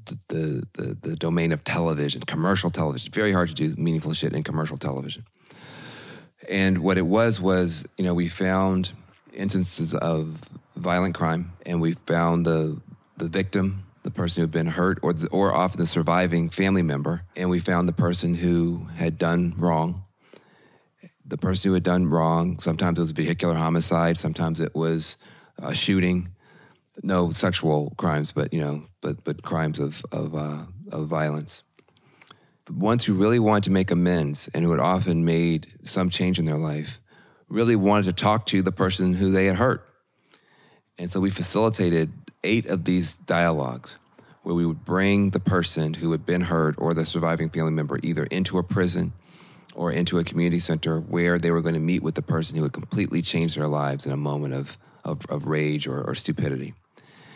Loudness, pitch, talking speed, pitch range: -24 LUFS, 85 Hz, 185 wpm, 80-95 Hz